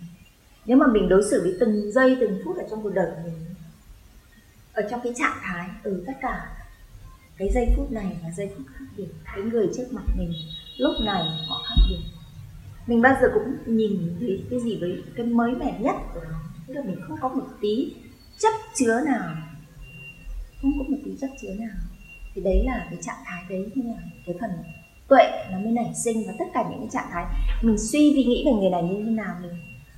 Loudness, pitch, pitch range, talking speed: -24 LUFS, 205 Hz, 175-250 Hz, 210 wpm